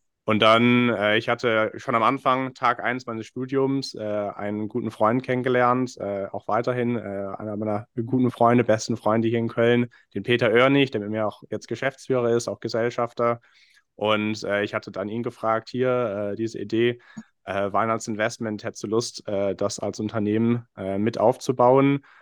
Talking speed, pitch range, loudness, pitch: 175 wpm, 105-120 Hz, -24 LUFS, 115 Hz